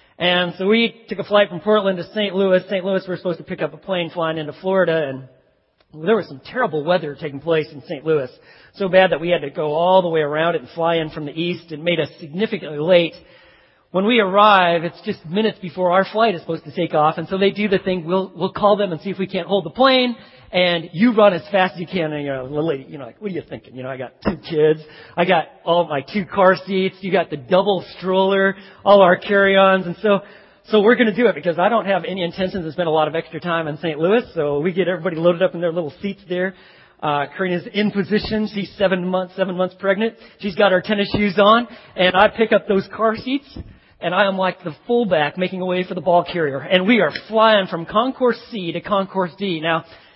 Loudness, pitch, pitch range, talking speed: -19 LUFS, 185 Hz, 165-200 Hz, 255 wpm